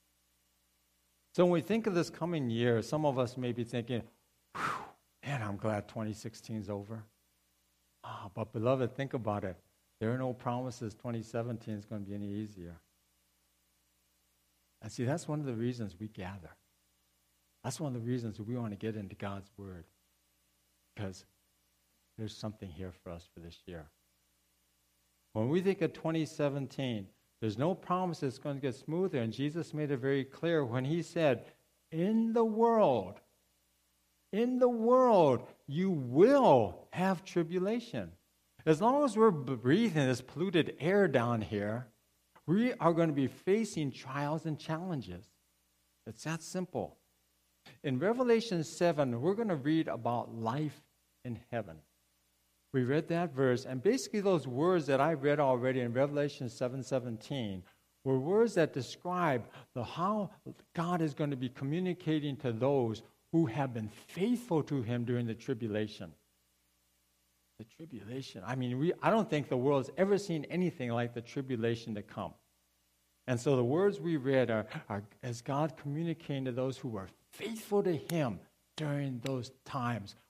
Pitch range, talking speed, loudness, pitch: 100-155 Hz, 155 wpm, -33 LUFS, 125 Hz